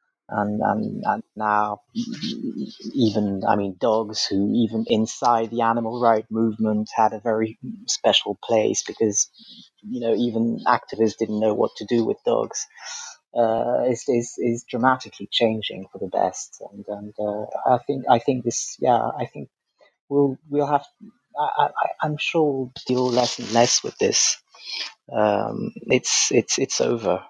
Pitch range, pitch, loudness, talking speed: 110-140 Hz, 115 Hz, -22 LUFS, 155 wpm